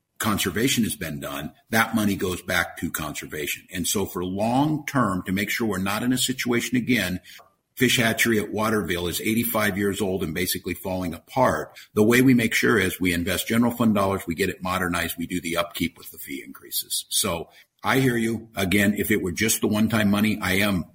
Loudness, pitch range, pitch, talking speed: -23 LUFS, 90-115 Hz, 105 Hz, 210 wpm